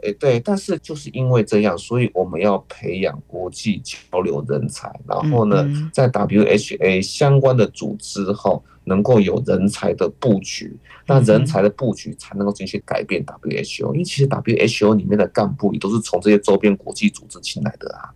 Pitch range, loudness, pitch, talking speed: 100-135 Hz, -19 LUFS, 105 Hz, 290 characters per minute